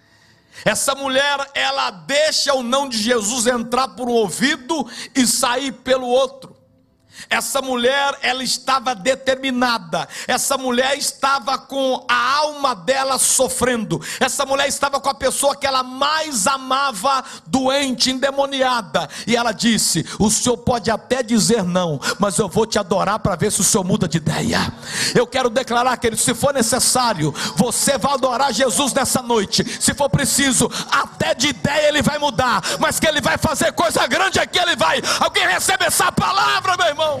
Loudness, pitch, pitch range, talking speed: -17 LUFS, 255 Hz, 230-275 Hz, 165 wpm